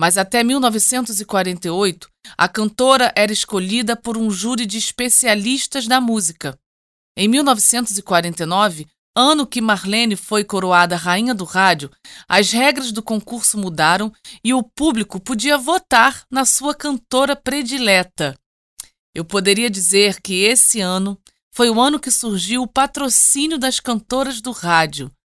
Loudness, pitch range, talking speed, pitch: -16 LUFS, 190-255 Hz, 130 wpm, 220 Hz